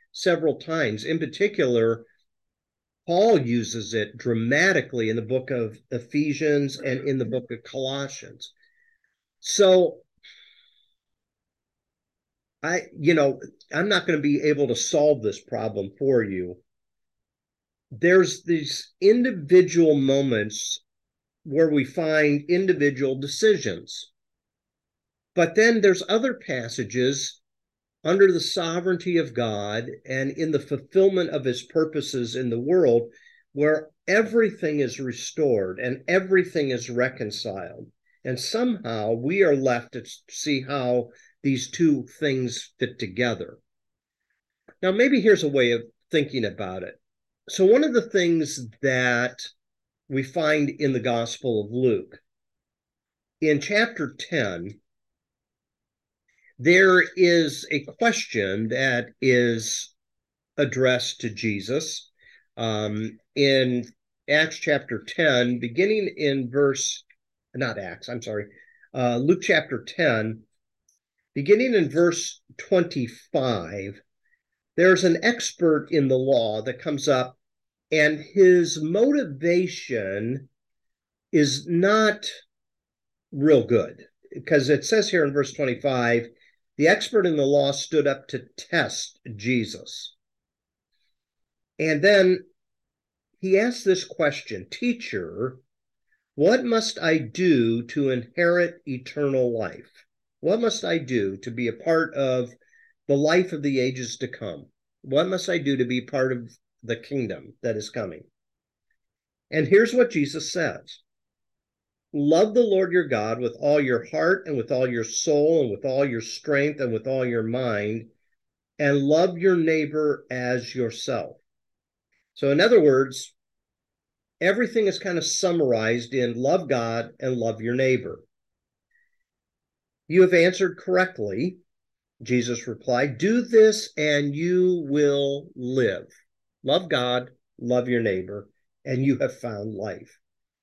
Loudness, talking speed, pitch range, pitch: -23 LUFS, 125 wpm, 120-175 Hz, 140 Hz